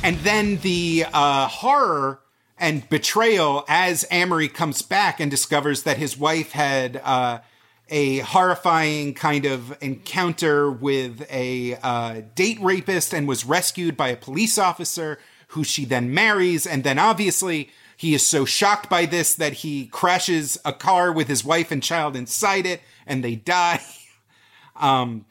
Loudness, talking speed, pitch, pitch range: -21 LUFS, 150 wpm, 150 Hz, 135-175 Hz